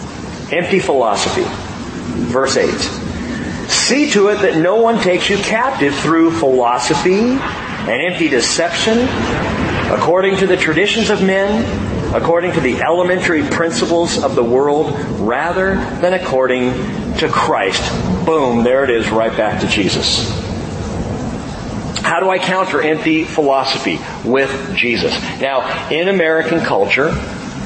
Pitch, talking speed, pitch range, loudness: 170 Hz, 125 wpm, 135-195 Hz, -15 LUFS